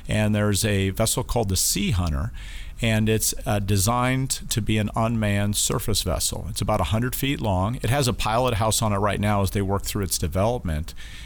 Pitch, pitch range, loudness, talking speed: 105 Hz, 100-115 Hz, -23 LUFS, 205 wpm